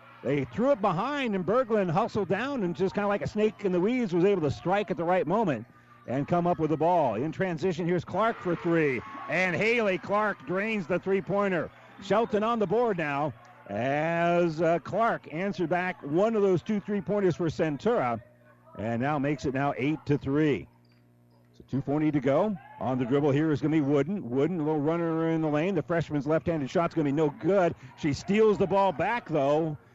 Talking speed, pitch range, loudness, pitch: 215 wpm, 145-195 Hz, -27 LUFS, 170 Hz